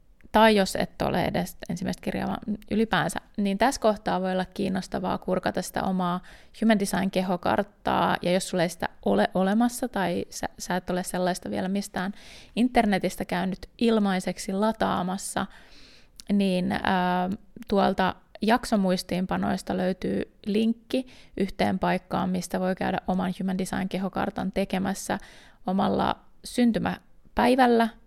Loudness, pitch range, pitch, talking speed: -26 LUFS, 185-220 Hz, 190 Hz, 120 wpm